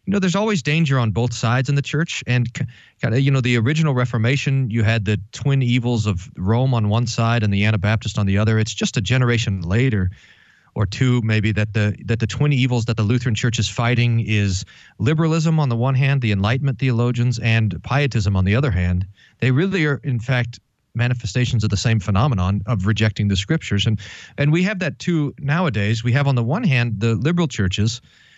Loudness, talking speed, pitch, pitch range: -19 LUFS, 205 wpm, 120 Hz, 110-135 Hz